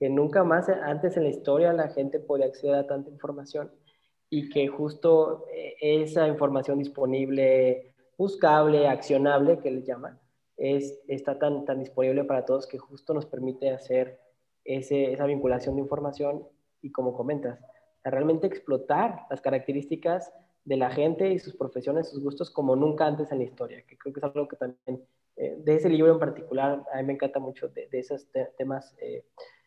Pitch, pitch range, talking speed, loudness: 140 Hz, 135-160 Hz, 180 wpm, -27 LUFS